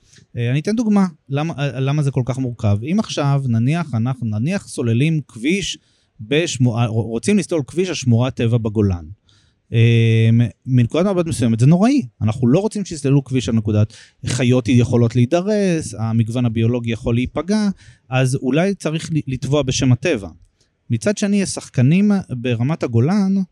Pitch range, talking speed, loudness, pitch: 115-160 Hz, 140 wpm, -18 LUFS, 130 Hz